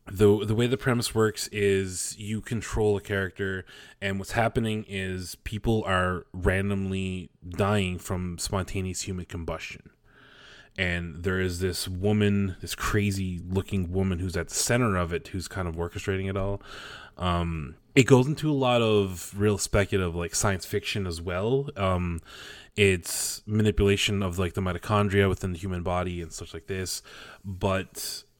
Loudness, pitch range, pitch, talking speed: -27 LUFS, 90-105 Hz, 95 Hz, 155 wpm